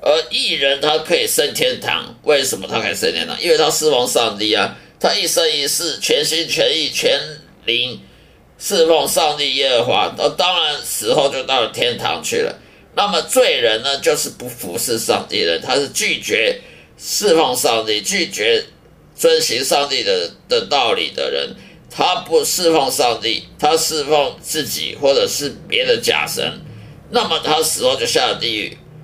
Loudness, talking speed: -16 LUFS, 245 characters per minute